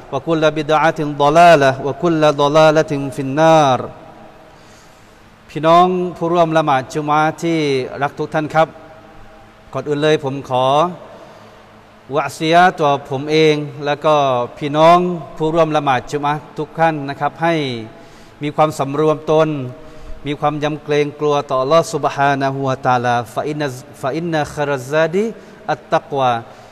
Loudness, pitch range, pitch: -16 LUFS, 140-160 Hz, 150 Hz